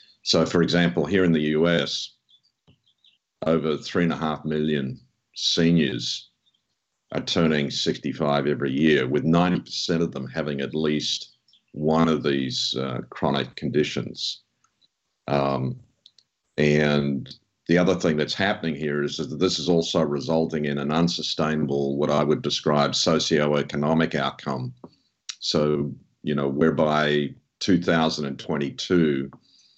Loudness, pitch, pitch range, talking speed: -23 LUFS, 75 Hz, 70-80 Hz, 120 wpm